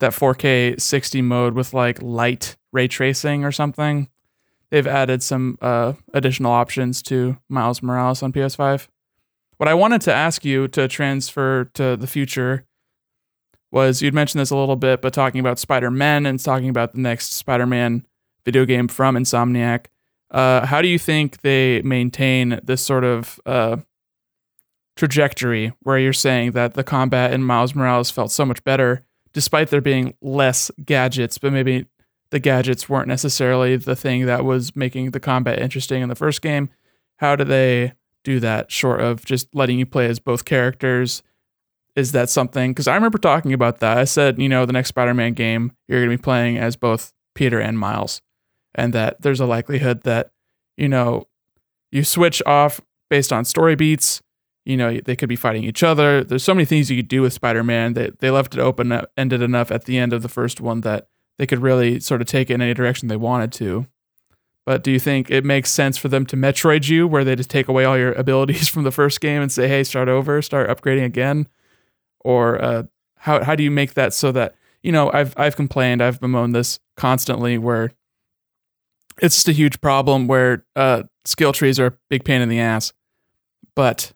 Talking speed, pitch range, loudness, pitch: 195 wpm, 120-140 Hz, -18 LUFS, 130 Hz